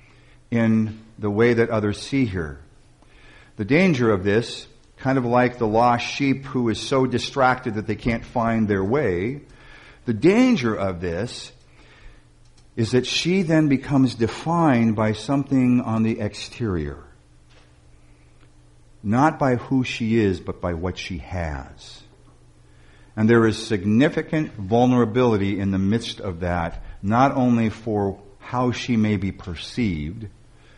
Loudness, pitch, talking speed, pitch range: -21 LUFS, 110 Hz, 135 wpm, 95-125 Hz